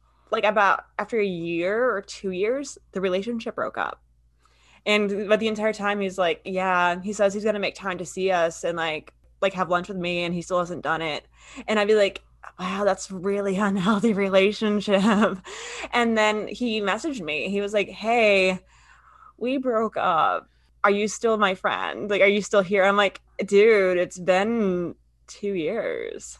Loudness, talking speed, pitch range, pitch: -23 LUFS, 185 wpm, 185-215 Hz, 200 Hz